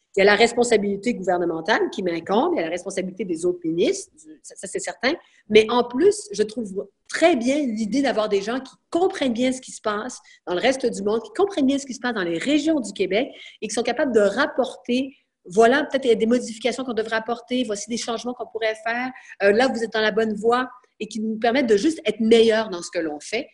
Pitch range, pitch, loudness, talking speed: 215-260 Hz, 235 Hz, -22 LUFS, 250 wpm